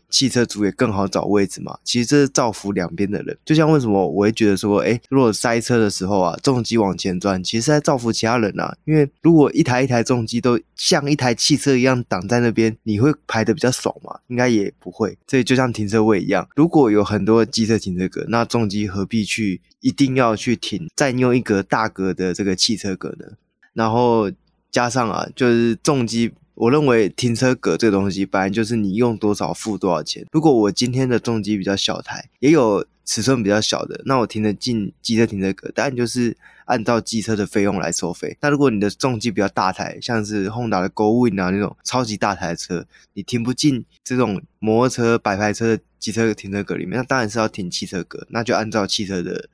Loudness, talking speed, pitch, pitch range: -19 LUFS, 325 characters per minute, 115 Hz, 100-125 Hz